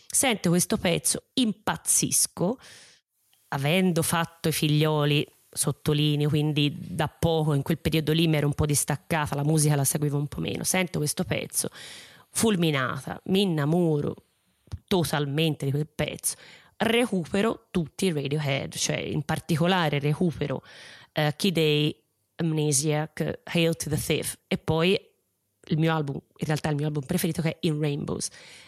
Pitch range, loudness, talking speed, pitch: 150-175 Hz, -26 LUFS, 145 wpm, 155 Hz